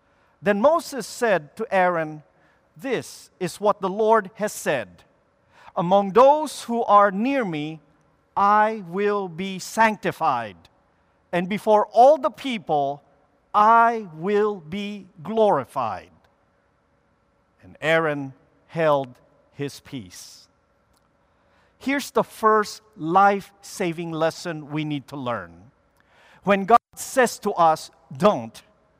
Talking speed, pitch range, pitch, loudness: 110 wpm, 145-210 Hz, 180 Hz, -22 LUFS